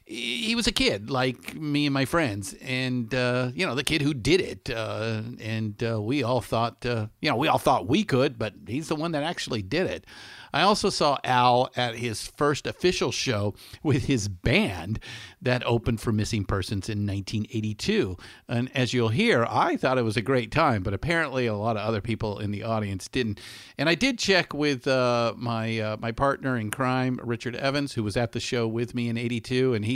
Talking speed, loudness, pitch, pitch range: 210 wpm, -26 LUFS, 120 Hz, 110-135 Hz